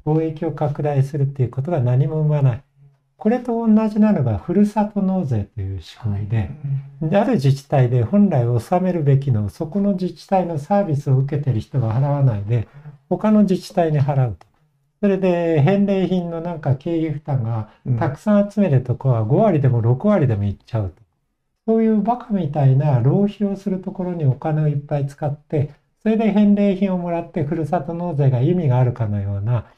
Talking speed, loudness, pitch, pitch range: 365 characters per minute, -19 LUFS, 150 Hz, 130-185 Hz